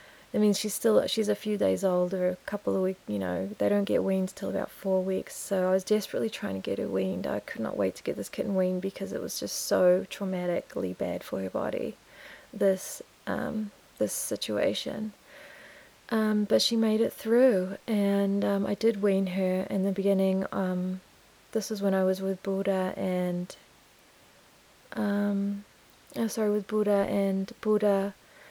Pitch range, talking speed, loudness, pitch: 185-210 Hz, 185 wpm, -29 LUFS, 195 Hz